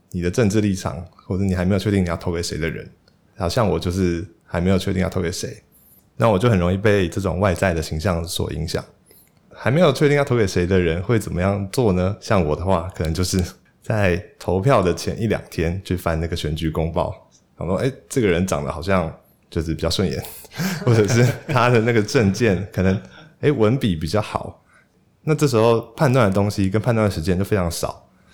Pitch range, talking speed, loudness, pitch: 90-110 Hz, 310 characters per minute, -20 LUFS, 95 Hz